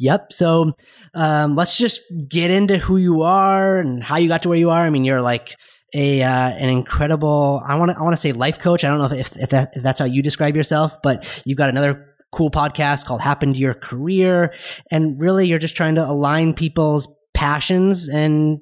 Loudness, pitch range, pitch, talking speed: -18 LUFS, 140-170 Hz, 150 Hz, 220 wpm